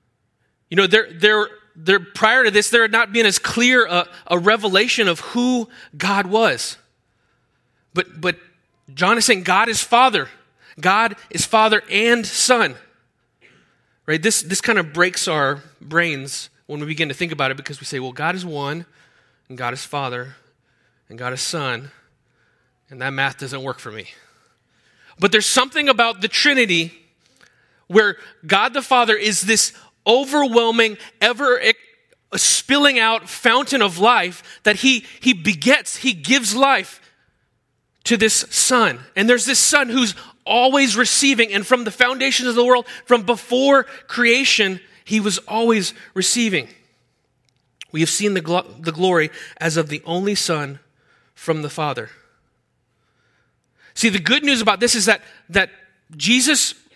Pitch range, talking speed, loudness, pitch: 155-240 Hz, 155 wpm, -17 LUFS, 205 Hz